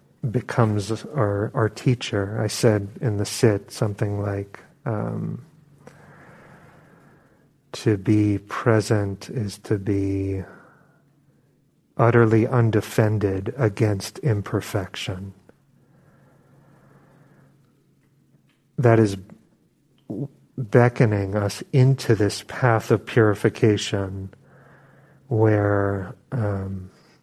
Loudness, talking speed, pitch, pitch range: -22 LUFS, 75 wpm, 110 Hz, 100-125 Hz